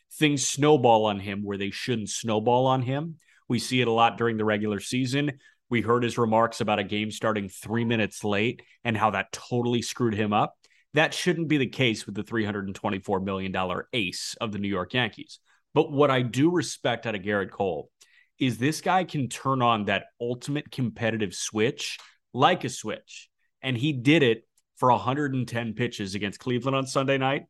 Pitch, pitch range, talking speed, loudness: 120 Hz, 105-135 Hz, 190 wpm, -26 LUFS